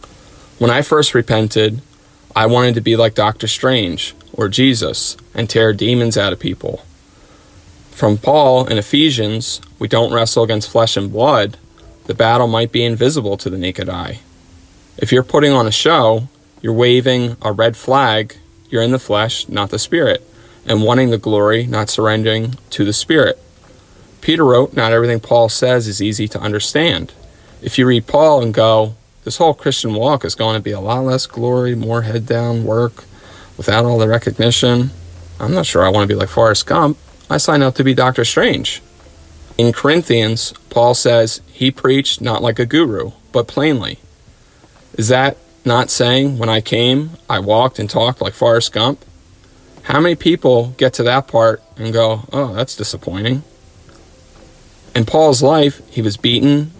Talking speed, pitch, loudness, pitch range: 170 wpm, 115 Hz, -14 LUFS, 105-125 Hz